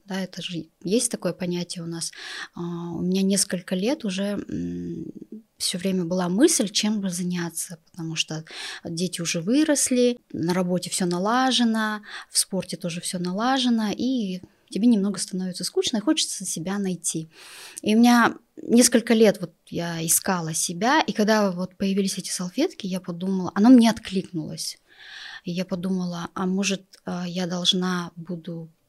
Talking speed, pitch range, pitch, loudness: 145 wpm, 175-220 Hz, 185 Hz, -24 LUFS